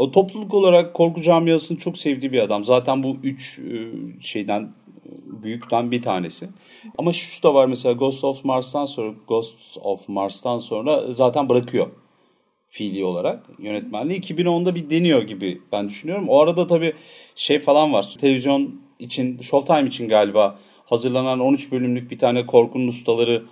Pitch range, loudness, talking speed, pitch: 120-165 Hz, -20 LUFS, 145 wpm, 135 Hz